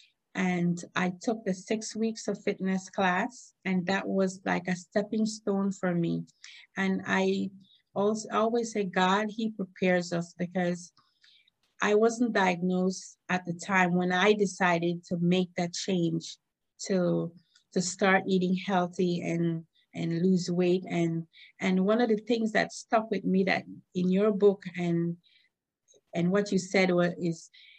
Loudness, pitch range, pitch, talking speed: -29 LUFS, 180-205 Hz, 185 Hz, 155 wpm